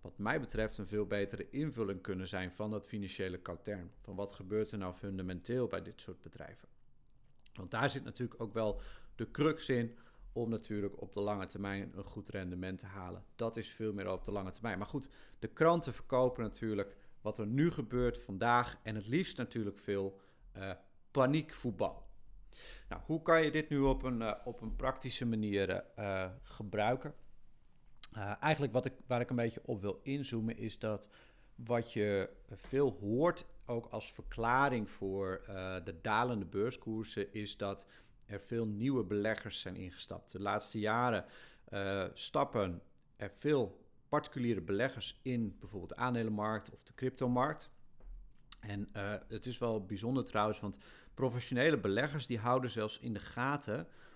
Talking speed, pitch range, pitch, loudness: 165 wpm, 100-125 Hz, 110 Hz, -38 LUFS